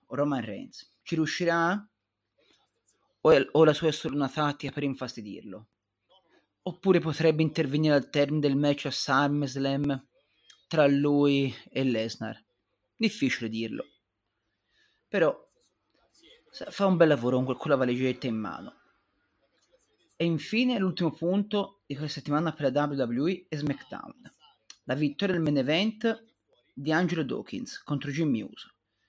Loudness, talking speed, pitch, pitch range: -28 LUFS, 125 wpm, 145 Hz, 140-170 Hz